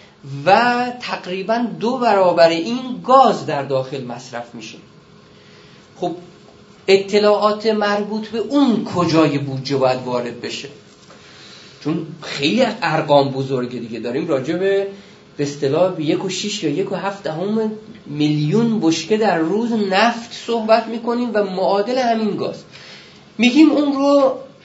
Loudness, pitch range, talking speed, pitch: -18 LUFS, 150-225 Hz, 125 wpm, 195 Hz